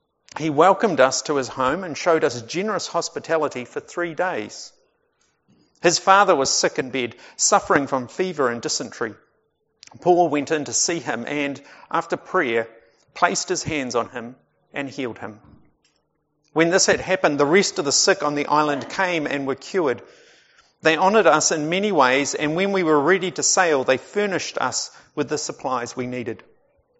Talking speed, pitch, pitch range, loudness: 175 wpm, 150 Hz, 130-175 Hz, -21 LUFS